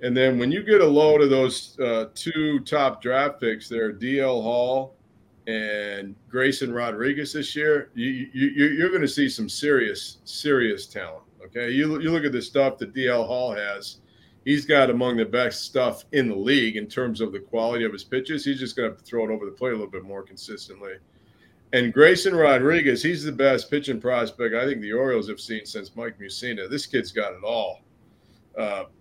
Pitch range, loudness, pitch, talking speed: 110-145 Hz, -23 LUFS, 125 Hz, 205 wpm